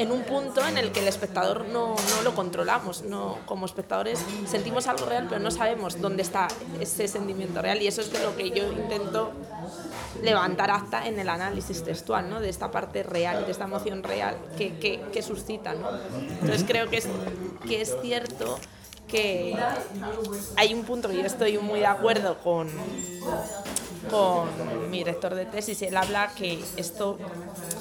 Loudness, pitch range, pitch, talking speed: -28 LUFS, 185-220 Hz, 205 Hz, 175 wpm